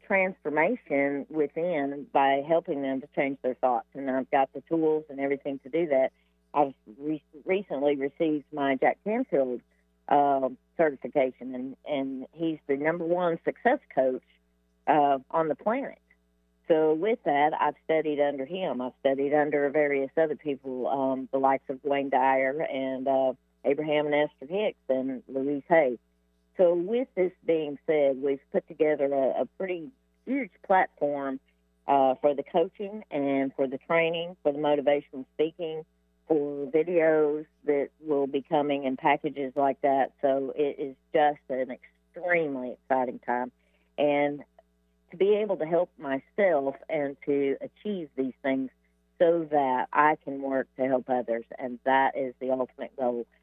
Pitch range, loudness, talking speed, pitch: 130-155 Hz, -28 LUFS, 155 wpm, 140 Hz